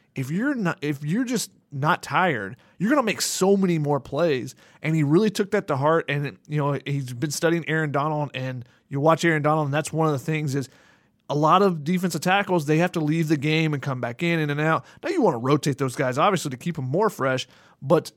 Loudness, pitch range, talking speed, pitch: -23 LUFS, 140-170 Hz, 250 wpm, 155 Hz